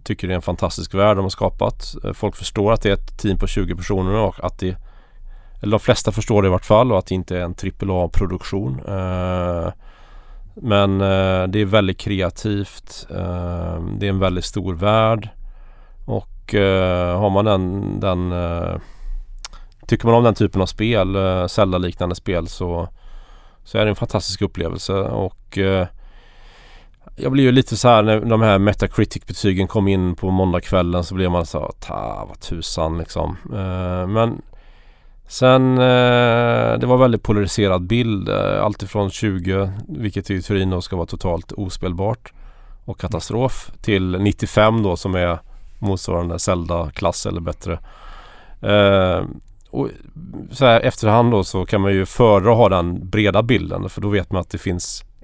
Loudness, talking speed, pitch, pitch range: -19 LUFS, 155 wpm, 95 Hz, 90-105 Hz